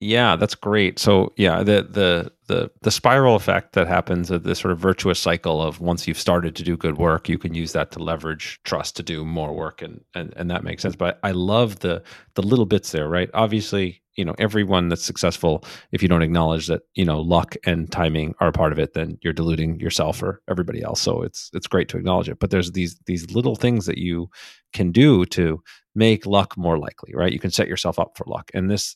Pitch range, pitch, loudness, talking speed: 85-100 Hz, 90 Hz, -21 LUFS, 235 wpm